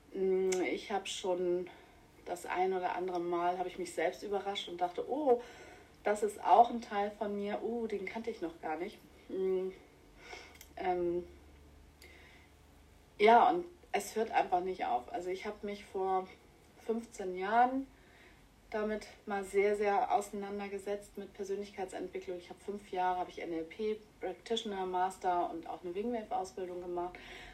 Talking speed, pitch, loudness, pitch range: 150 wpm, 200 Hz, -35 LUFS, 180-235 Hz